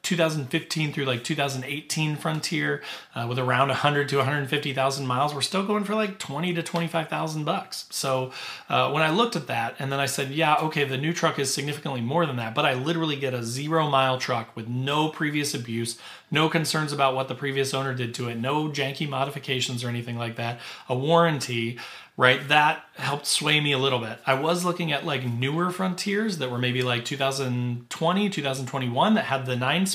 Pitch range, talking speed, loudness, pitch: 130-160 Hz, 200 wpm, -25 LUFS, 140 Hz